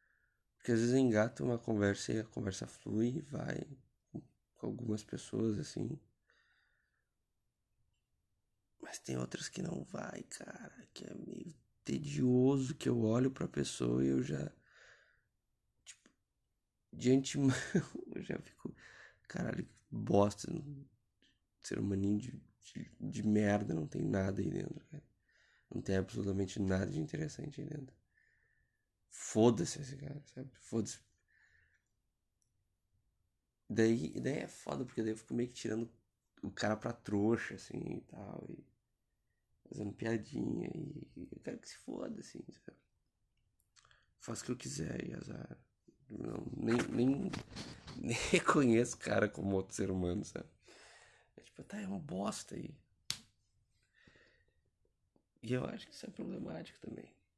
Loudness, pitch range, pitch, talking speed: -38 LUFS, 100-130 Hz, 115 Hz, 135 wpm